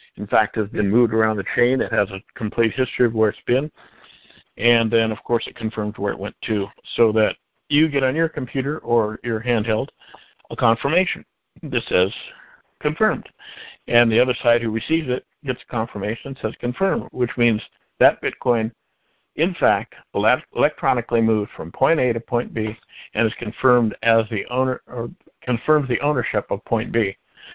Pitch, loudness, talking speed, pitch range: 120 Hz, -21 LUFS, 180 wpm, 110-130 Hz